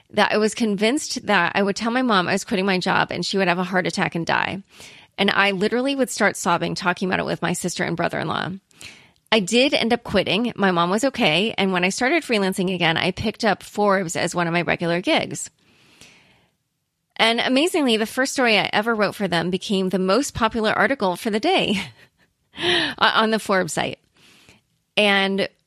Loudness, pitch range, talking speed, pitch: -20 LUFS, 180-220 Hz, 200 wpm, 195 Hz